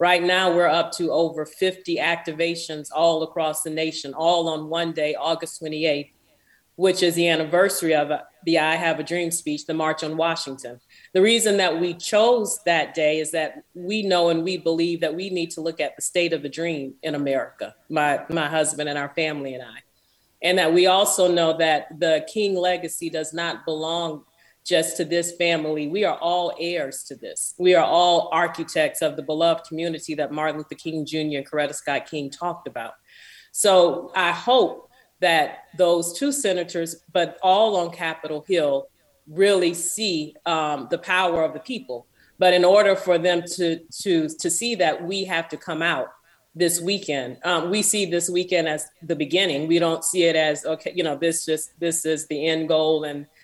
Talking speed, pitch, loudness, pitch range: 190 wpm, 165 Hz, -22 LUFS, 155-180 Hz